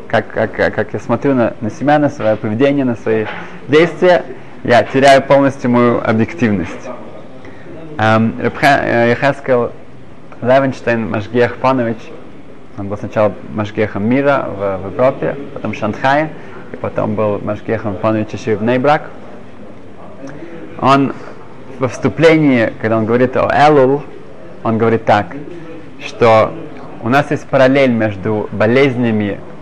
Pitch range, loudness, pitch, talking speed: 110-135 Hz, -14 LUFS, 120 Hz, 125 wpm